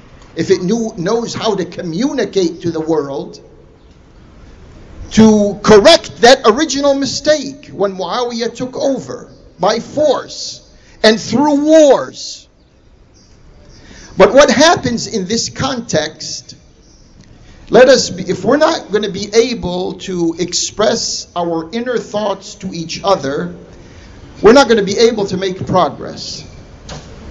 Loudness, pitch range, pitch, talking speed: -13 LUFS, 175-240 Hz, 210 Hz, 125 wpm